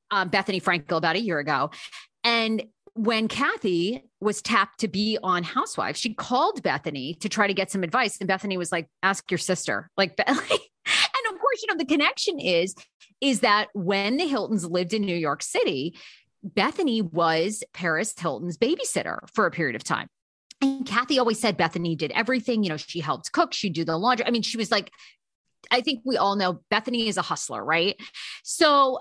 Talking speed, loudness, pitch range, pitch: 190 wpm, -25 LUFS, 185-255 Hz, 215 Hz